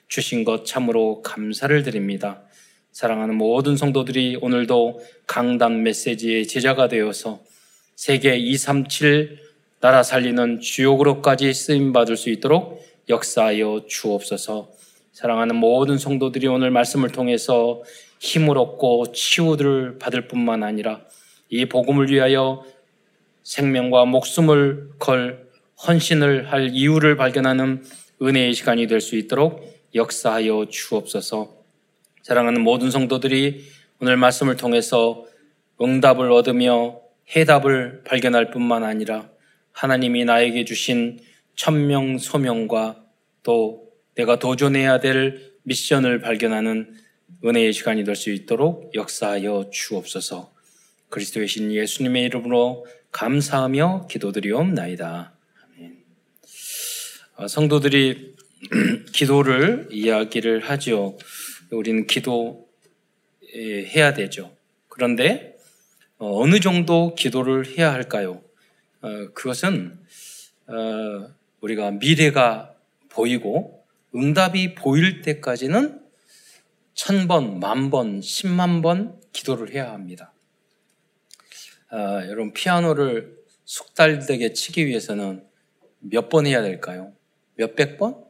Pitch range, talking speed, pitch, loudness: 115-145 Hz, 240 characters per minute, 125 Hz, -20 LUFS